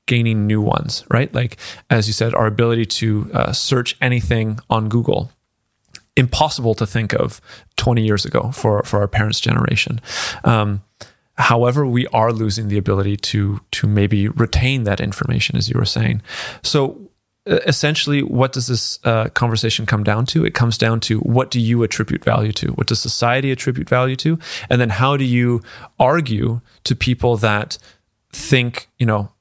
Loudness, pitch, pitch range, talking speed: -18 LUFS, 115 Hz, 110-130 Hz, 165 wpm